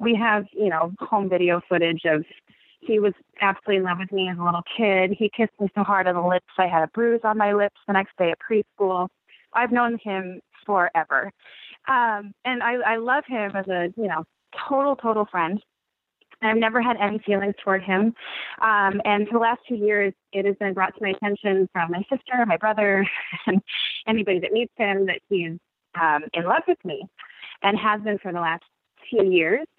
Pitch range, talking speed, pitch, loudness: 190-225 Hz, 205 wpm, 205 Hz, -23 LUFS